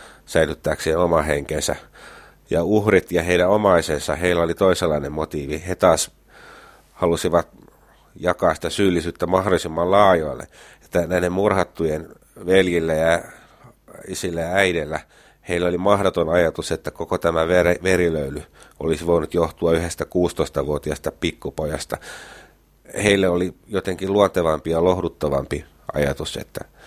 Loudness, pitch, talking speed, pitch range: -21 LUFS, 85 Hz, 110 wpm, 80-95 Hz